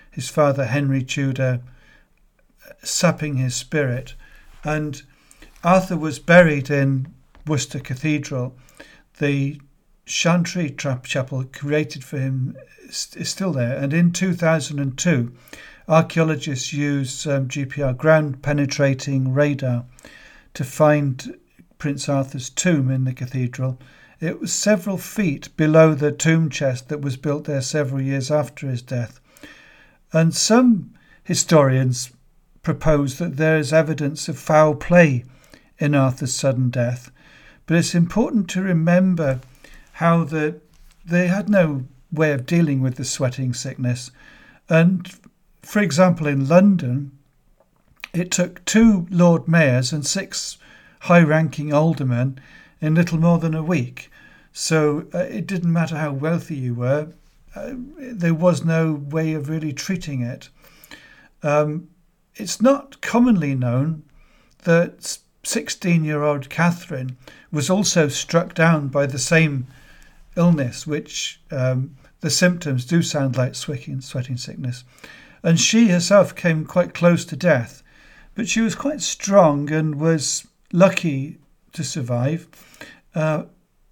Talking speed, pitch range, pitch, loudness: 130 wpm, 135-170 Hz, 150 Hz, -20 LUFS